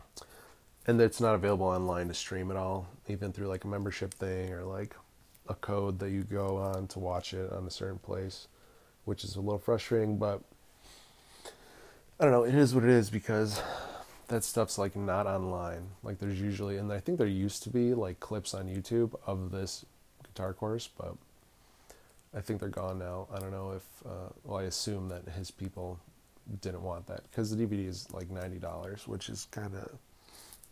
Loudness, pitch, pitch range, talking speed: -34 LUFS, 100 Hz, 95-105 Hz, 190 wpm